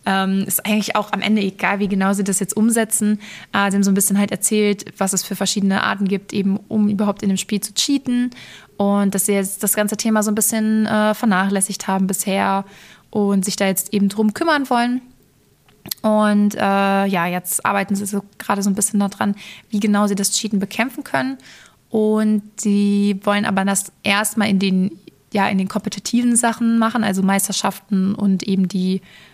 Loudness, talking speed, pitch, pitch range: -18 LUFS, 190 wpm, 200 Hz, 195-215 Hz